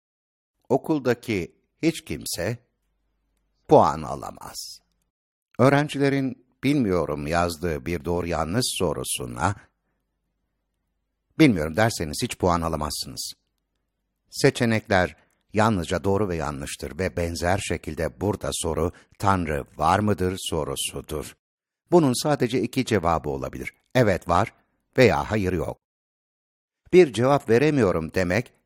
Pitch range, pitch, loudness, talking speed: 85-120 Hz, 95 Hz, -24 LUFS, 95 wpm